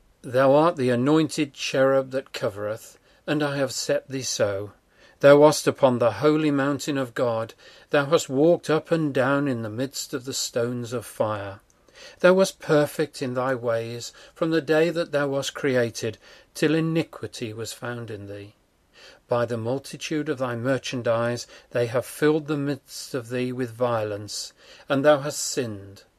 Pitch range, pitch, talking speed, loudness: 120-150 Hz, 135 Hz, 165 wpm, -24 LUFS